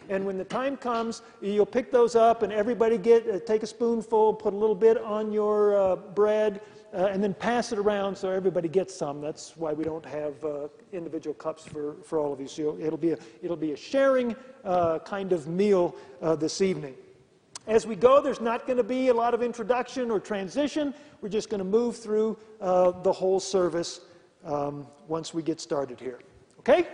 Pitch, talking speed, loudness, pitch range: 200 Hz, 205 wpm, -27 LUFS, 165-230 Hz